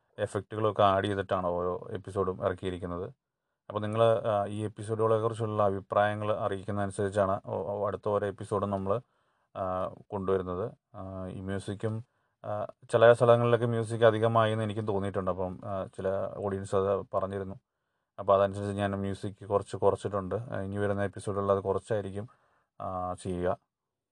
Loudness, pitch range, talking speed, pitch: -30 LUFS, 95-110 Hz, 110 wpm, 100 Hz